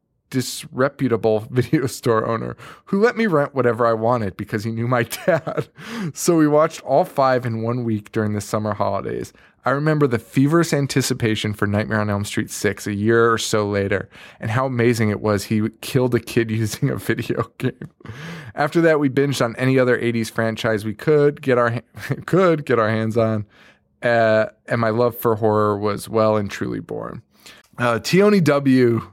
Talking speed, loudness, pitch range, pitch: 185 wpm, -20 LUFS, 110-140 Hz, 120 Hz